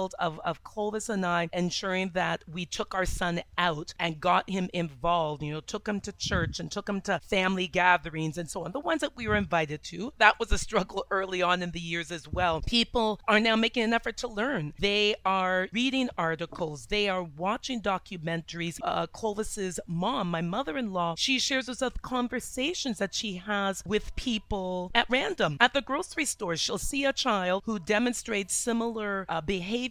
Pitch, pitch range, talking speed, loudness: 200 Hz, 175-230 Hz, 195 wpm, -29 LUFS